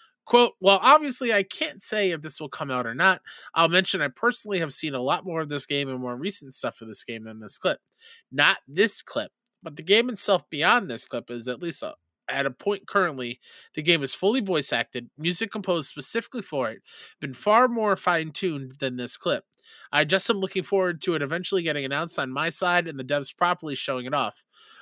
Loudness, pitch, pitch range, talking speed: -25 LUFS, 170 Hz, 140-200 Hz, 220 wpm